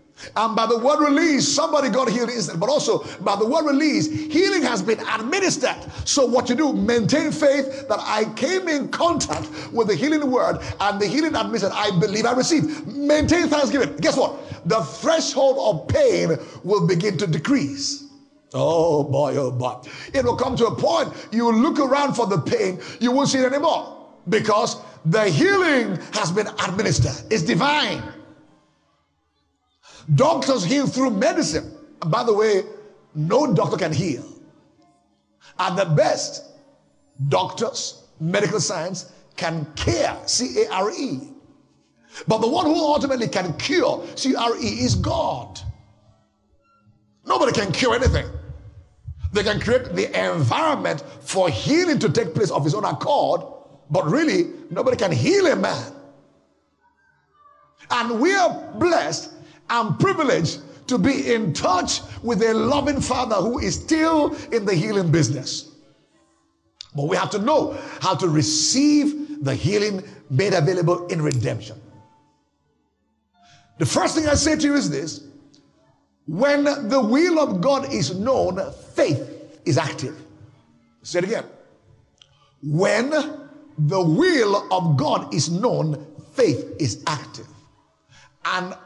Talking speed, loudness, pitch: 145 wpm, -21 LUFS, 225 Hz